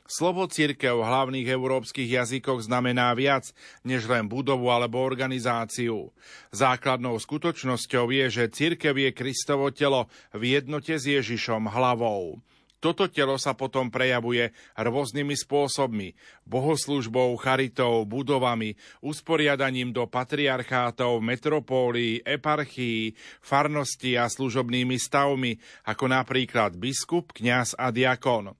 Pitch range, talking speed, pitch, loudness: 120-140 Hz, 105 wpm, 130 Hz, -26 LUFS